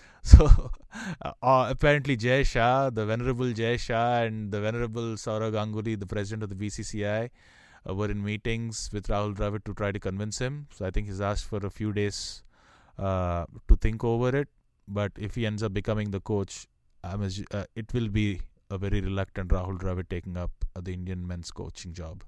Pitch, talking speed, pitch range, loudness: 105 Hz, 195 wpm, 95-115 Hz, -28 LUFS